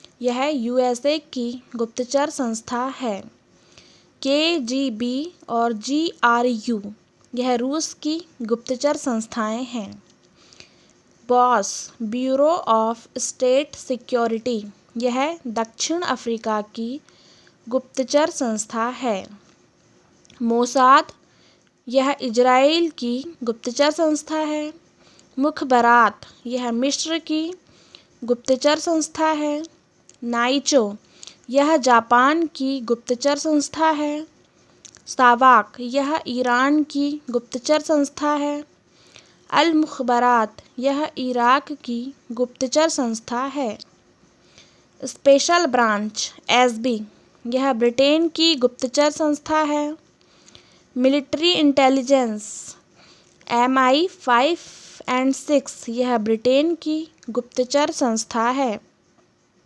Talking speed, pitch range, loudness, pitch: 90 wpm, 240-295 Hz, -20 LUFS, 260 Hz